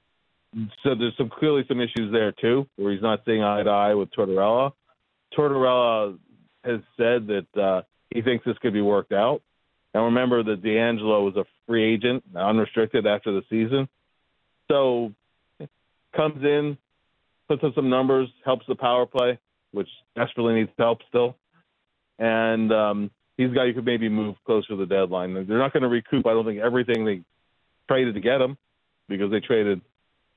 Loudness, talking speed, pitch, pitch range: -24 LUFS, 170 wpm, 115 Hz, 105-125 Hz